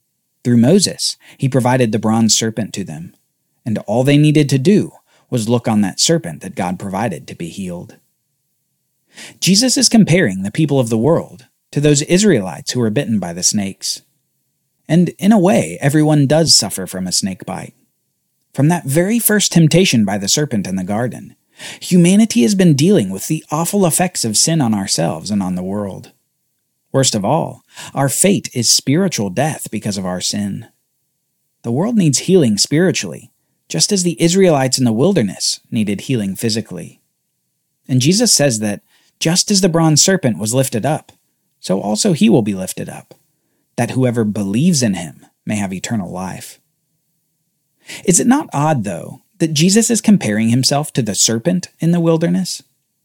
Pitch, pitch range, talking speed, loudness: 150 Hz, 115-175 Hz, 170 wpm, -14 LUFS